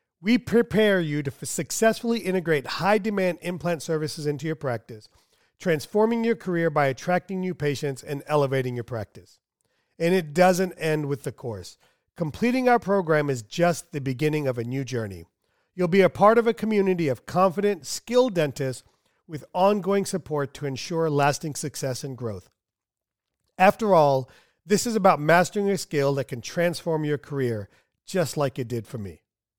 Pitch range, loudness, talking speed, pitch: 135-185 Hz, -24 LUFS, 165 wpm, 155 Hz